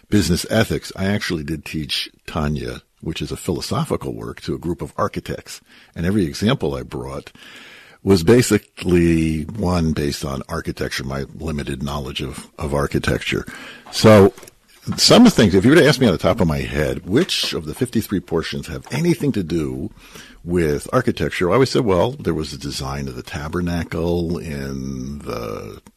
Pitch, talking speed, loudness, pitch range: 80 Hz, 175 wpm, -19 LUFS, 70-95 Hz